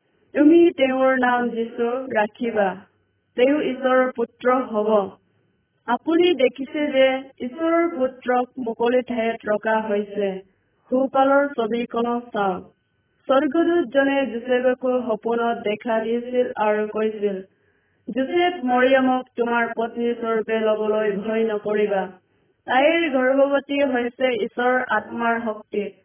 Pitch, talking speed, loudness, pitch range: 240 Hz, 95 wpm, -21 LUFS, 215-260 Hz